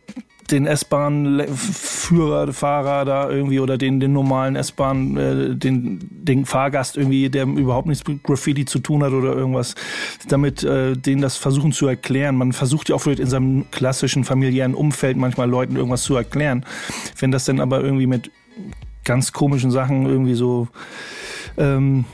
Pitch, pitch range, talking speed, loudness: 135 Hz, 130-145 Hz, 160 wpm, -19 LUFS